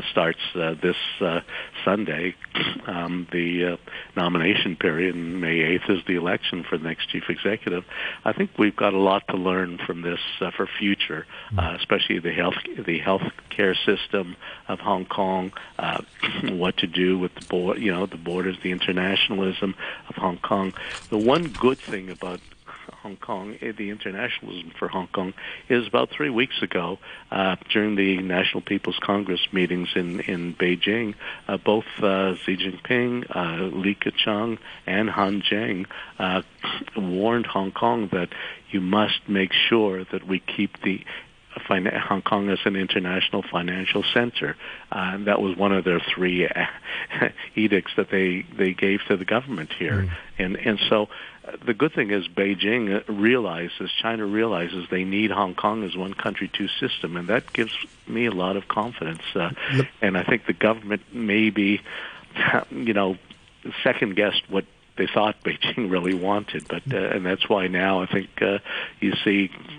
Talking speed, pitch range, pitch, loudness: 170 wpm, 90-105 Hz, 95 Hz, -24 LUFS